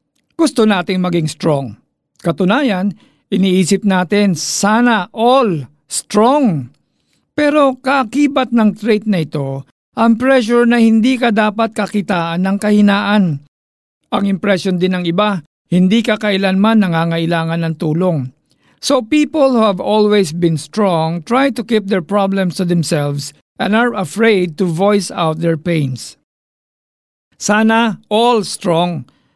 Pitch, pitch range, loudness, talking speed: 195 Hz, 170-225 Hz, -14 LUFS, 125 wpm